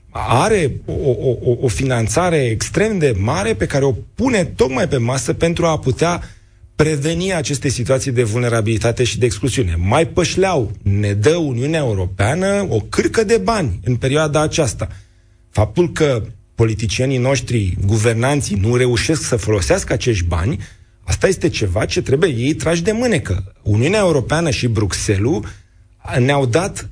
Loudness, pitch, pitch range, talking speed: -17 LUFS, 125 Hz, 105-155 Hz, 145 wpm